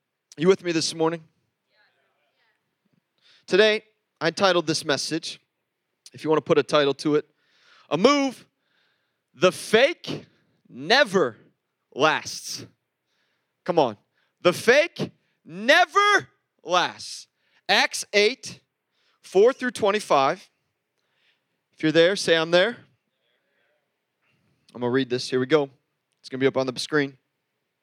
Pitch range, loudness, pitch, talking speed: 145-210 Hz, -22 LUFS, 165 Hz, 125 wpm